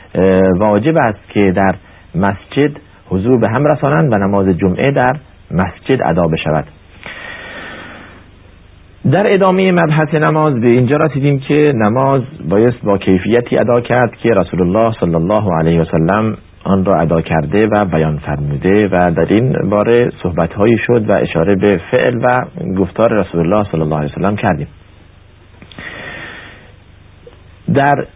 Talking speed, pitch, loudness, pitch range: 145 wpm, 100 Hz, -13 LUFS, 90-120 Hz